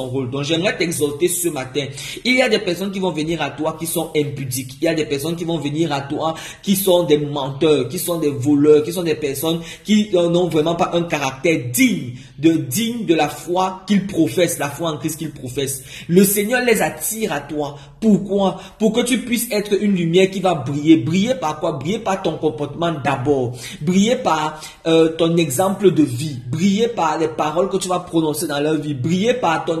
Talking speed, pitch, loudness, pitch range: 215 wpm, 165 Hz, -19 LUFS, 150-185 Hz